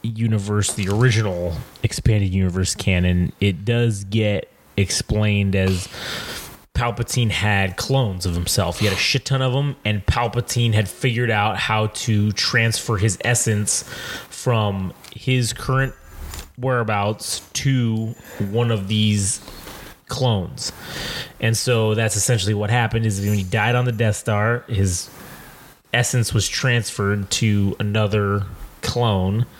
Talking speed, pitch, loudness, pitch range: 130 wpm, 110 Hz, -20 LUFS, 100-120 Hz